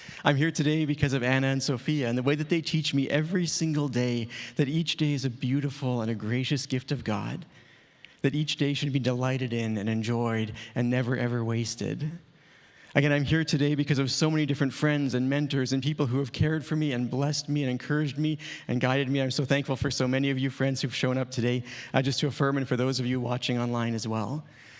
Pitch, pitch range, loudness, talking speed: 135 Hz, 125-145 Hz, -28 LUFS, 235 wpm